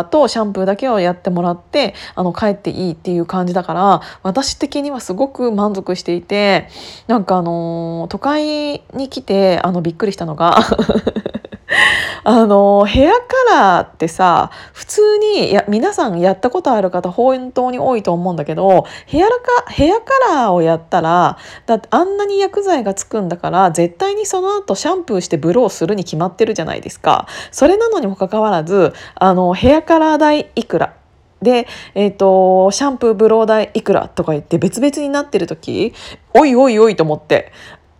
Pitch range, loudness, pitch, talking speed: 180-280 Hz, -14 LUFS, 215 Hz, 355 characters per minute